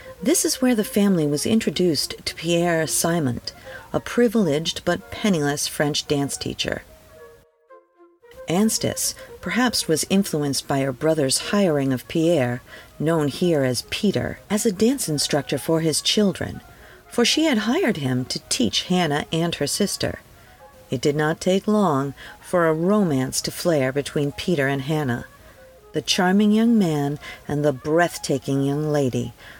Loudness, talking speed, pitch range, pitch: -21 LUFS, 145 wpm, 140-205 Hz, 160 Hz